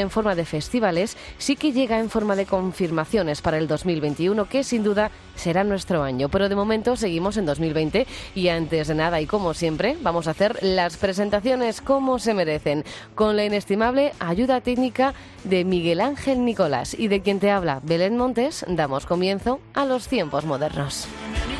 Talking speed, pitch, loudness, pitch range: 175 wpm, 195 Hz, -23 LUFS, 165-230 Hz